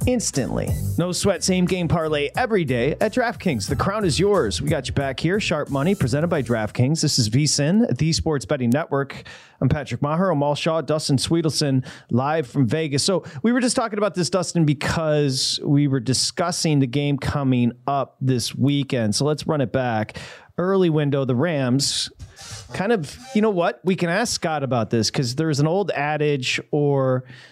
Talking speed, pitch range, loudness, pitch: 190 wpm, 130-165 Hz, -21 LUFS, 145 Hz